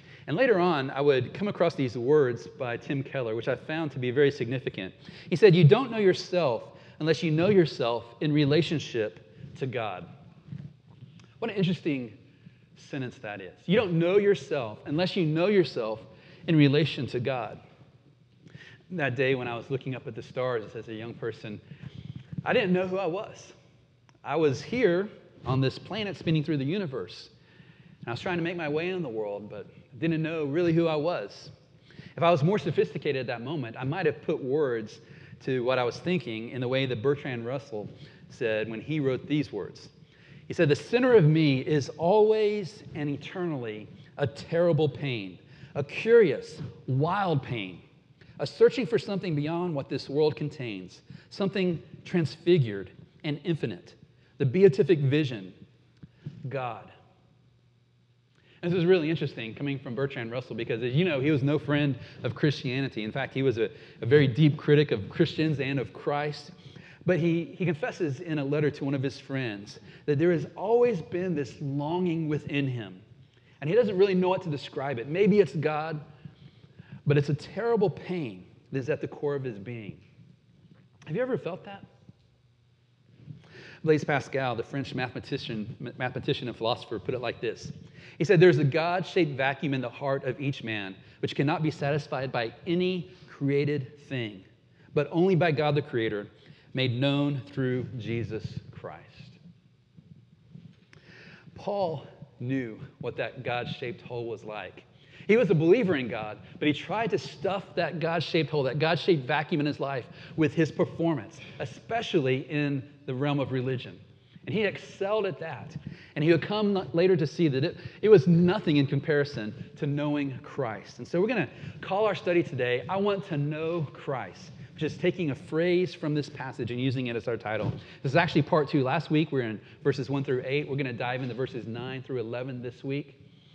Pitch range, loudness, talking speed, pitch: 130-165 Hz, -28 LUFS, 180 wpm, 145 Hz